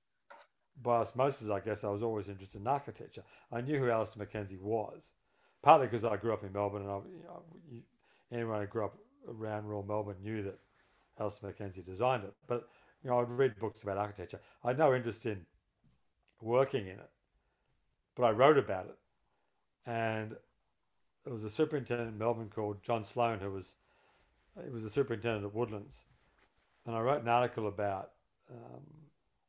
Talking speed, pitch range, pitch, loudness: 175 wpm, 100-120 Hz, 115 Hz, -35 LUFS